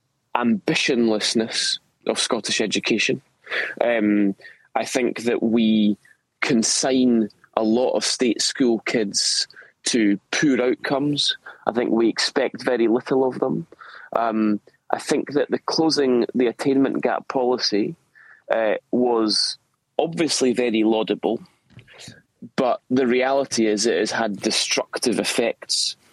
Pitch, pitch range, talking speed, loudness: 120 Hz, 110-135 Hz, 115 wpm, -21 LUFS